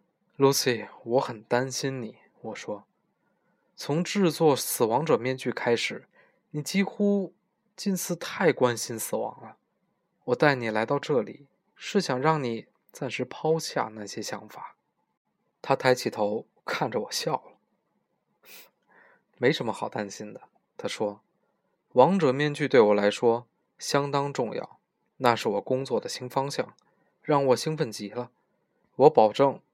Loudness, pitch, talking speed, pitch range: -26 LUFS, 140 Hz, 200 characters per minute, 120-160 Hz